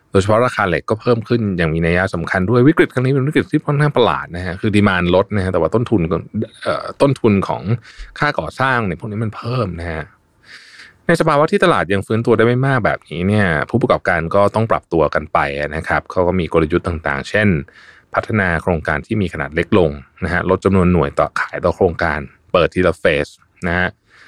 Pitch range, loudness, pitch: 85-115 Hz, -17 LUFS, 100 Hz